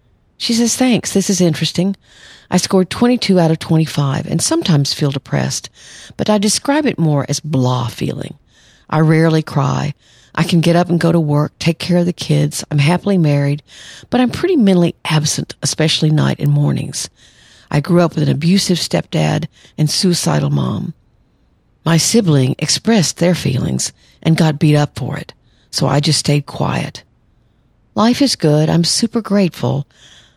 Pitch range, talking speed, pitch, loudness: 145-180 Hz, 165 wpm, 155 Hz, -15 LUFS